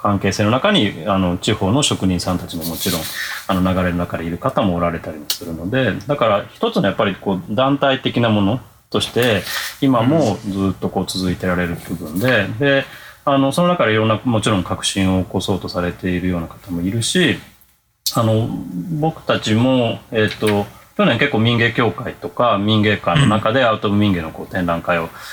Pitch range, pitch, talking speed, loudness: 90-120 Hz, 105 Hz, 365 characters per minute, -18 LUFS